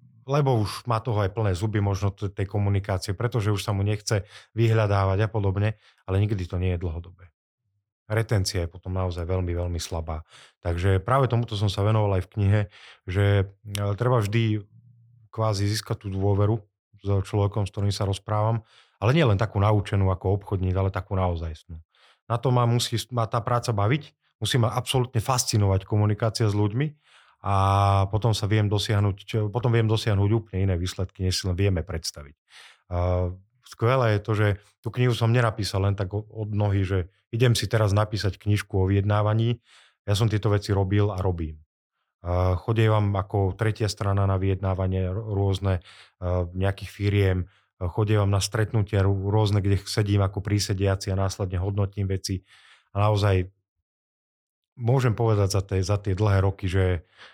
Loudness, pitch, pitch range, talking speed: -25 LUFS, 100 Hz, 95-110 Hz, 160 wpm